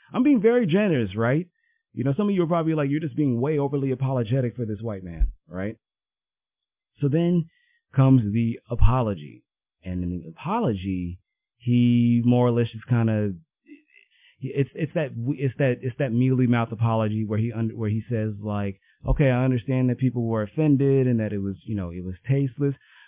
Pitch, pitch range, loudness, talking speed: 120 Hz, 110-140 Hz, -24 LUFS, 190 wpm